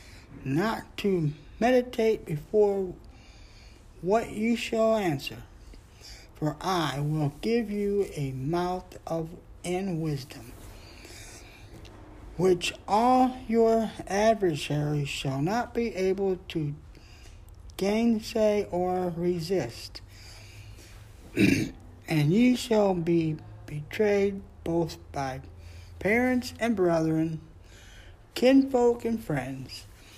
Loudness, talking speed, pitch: -27 LUFS, 85 wpm, 160 Hz